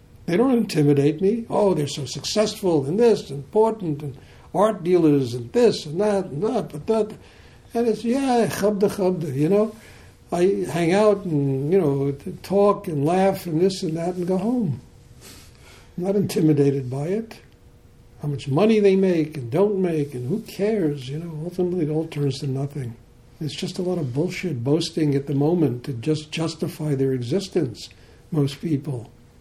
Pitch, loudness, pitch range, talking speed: 165 Hz, -22 LUFS, 140-195 Hz, 175 wpm